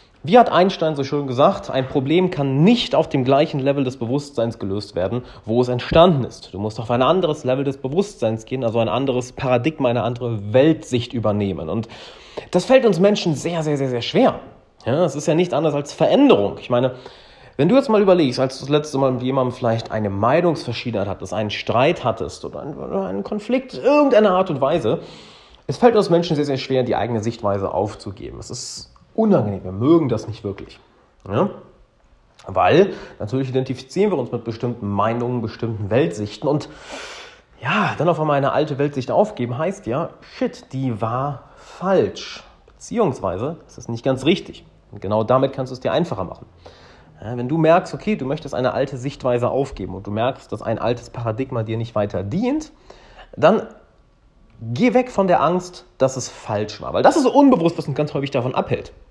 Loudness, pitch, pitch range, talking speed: -20 LUFS, 130 Hz, 115-160 Hz, 195 wpm